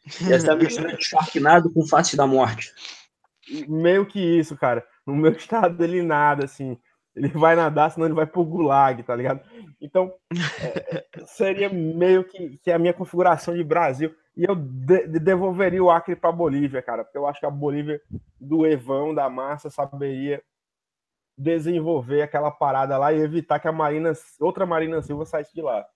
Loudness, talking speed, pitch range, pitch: -22 LUFS, 160 wpm, 145-175 Hz, 160 Hz